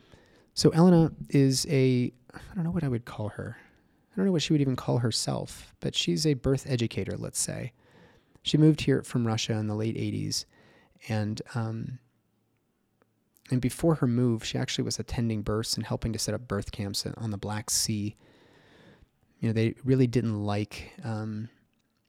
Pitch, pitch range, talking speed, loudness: 120 Hz, 110-135 Hz, 175 wpm, -28 LUFS